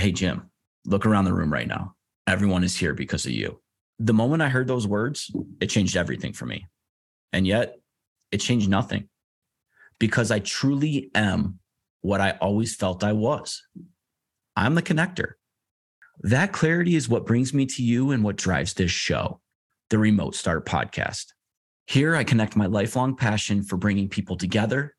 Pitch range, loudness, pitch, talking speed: 95-130 Hz, -24 LUFS, 105 Hz, 170 wpm